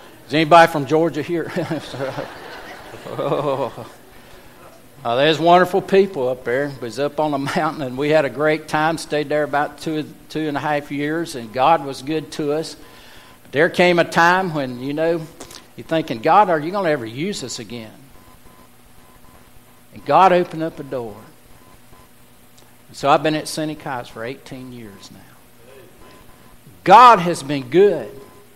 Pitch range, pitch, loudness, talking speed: 140-165 Hz, 155 Hz, -18 LUFS, 160 wpm